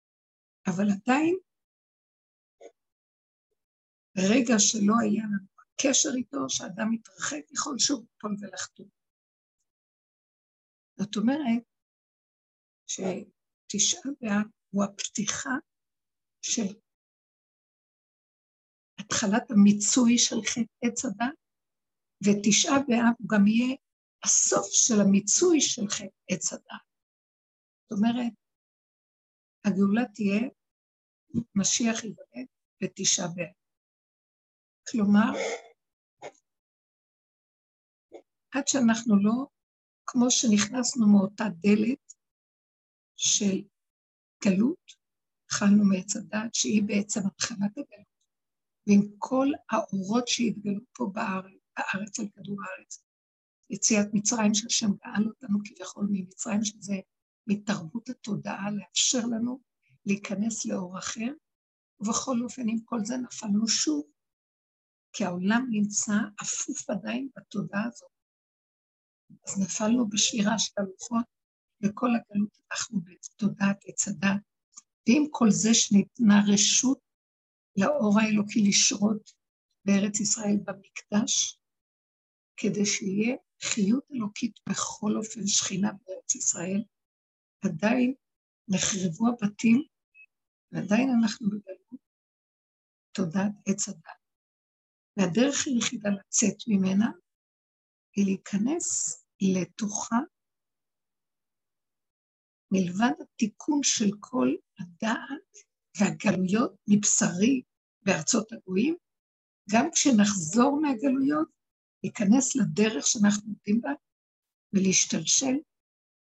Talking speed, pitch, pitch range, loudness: 85 wpm, 215 Hz, 200-245 Hz, -26 LUFS